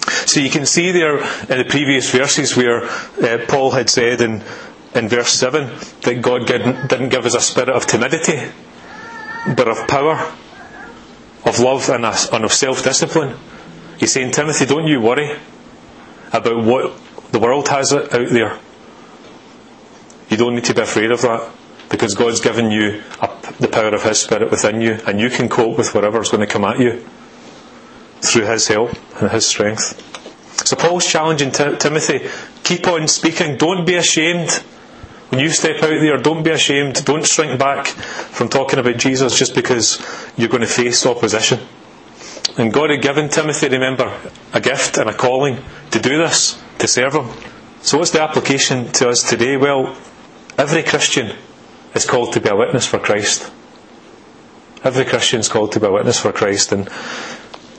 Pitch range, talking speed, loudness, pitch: 120-155 Hz, 170 wpm, -15 LUFS, 135 Hz